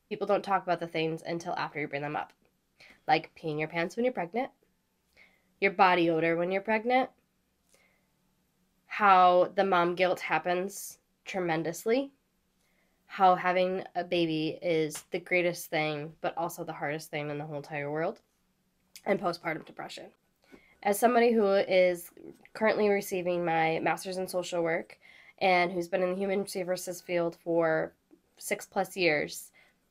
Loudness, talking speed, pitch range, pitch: -29 LUFS, 150 wpm, 165-195 Hz, 180 Hz